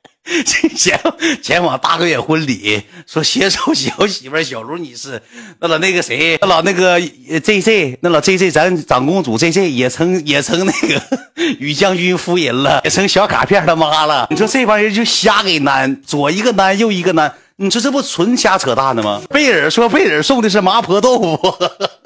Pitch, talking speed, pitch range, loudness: 185 Hz, 270 characters per minute, 155-215 Hz, -13 LUFS